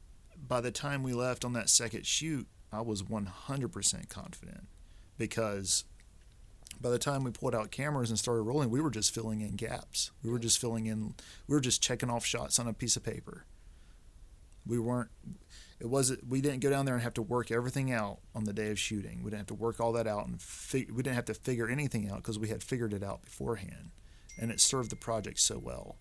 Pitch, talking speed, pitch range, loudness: 115 Hz, 225 wpm, 105-125 Hz, -33 LUFS